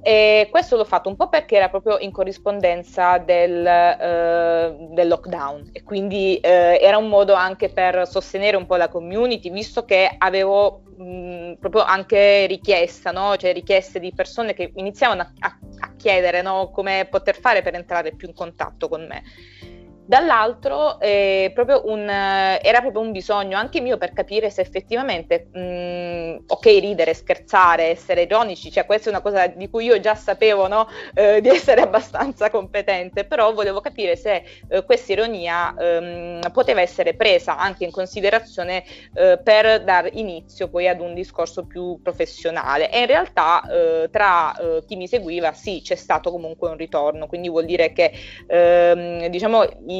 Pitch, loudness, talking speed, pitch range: 190 Hz, -18 LUFS, 165 wpm, 175-215 Hz